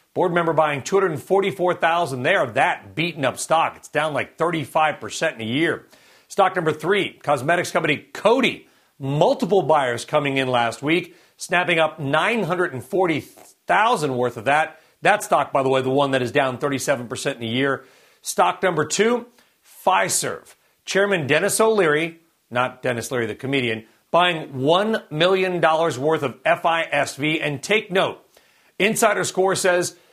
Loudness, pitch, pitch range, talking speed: -21 LUFS, 160 Hz, 135-180 Hz, 145 wpm